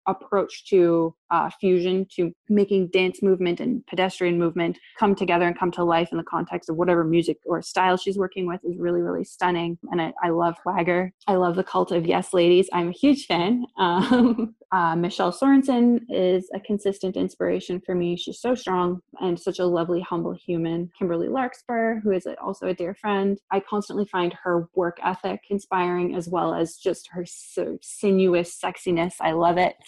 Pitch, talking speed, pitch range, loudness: 180 Hz, 190 wpm, 175-195 Hz, -23 LUFS